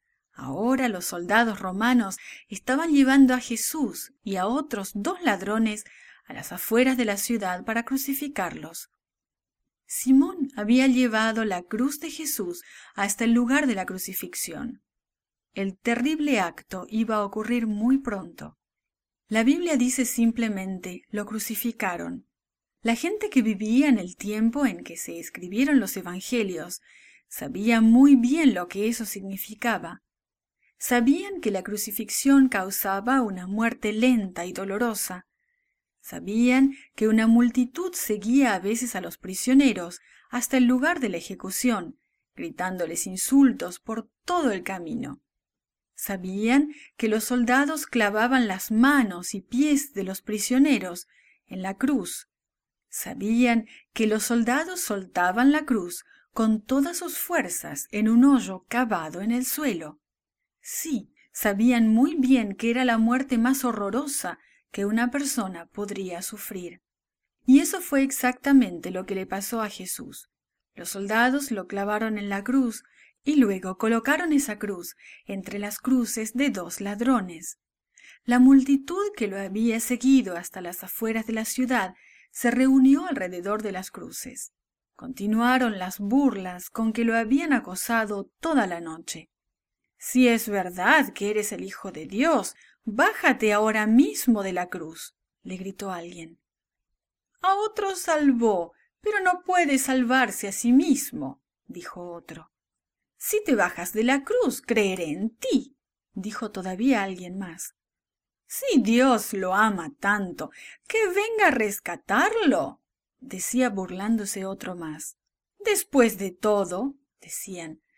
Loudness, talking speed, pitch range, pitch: -24 LUFS, 135 wpm, 200-265 Hz, 230 Hz